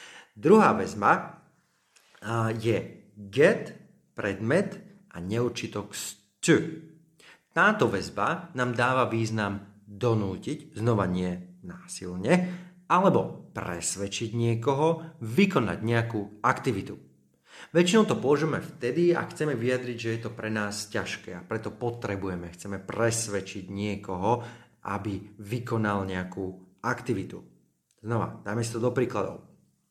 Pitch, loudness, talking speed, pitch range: 115 Hz, -28 LUFS, 100 wpm, 100-140 Hz